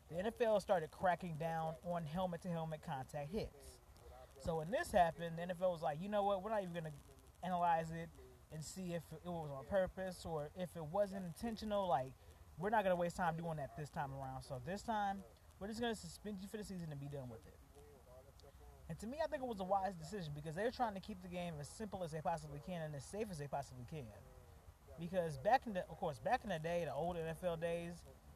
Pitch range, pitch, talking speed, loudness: 150-195 Hz, 170 Hz, 240 wpm, -43 LUFS